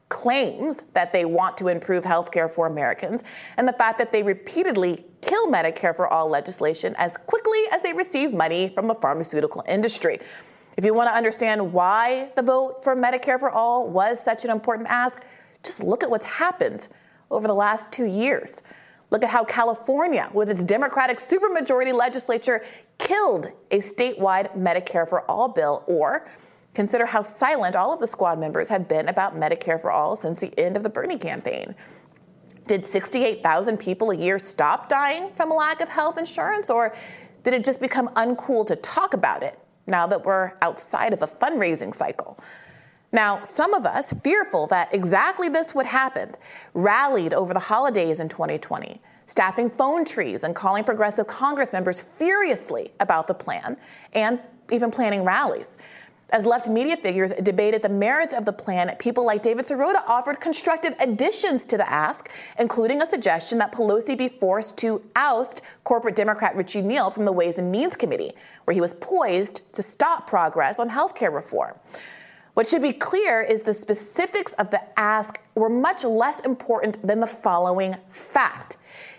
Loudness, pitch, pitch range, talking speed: -22 LUFS, 230 Hz, 195-265 Hz, 170 wpm